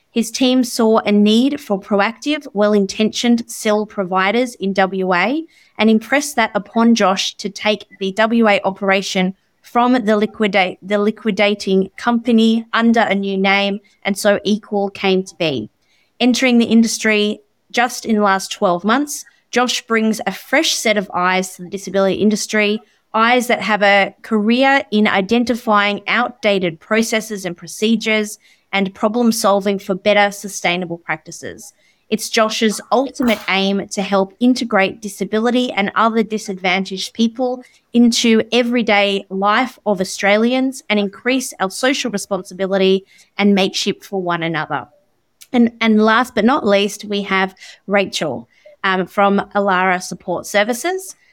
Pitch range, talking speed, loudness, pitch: 195-230 Hz, 135 wpm, -16 LUFS, 210 Hz